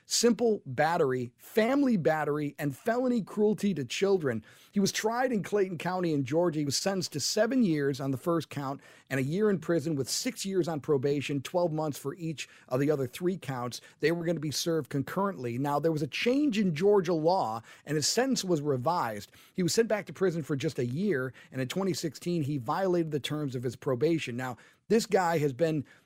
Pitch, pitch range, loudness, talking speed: 165 Hz, 140-195 Hz, -30 LUFS, 210 wpm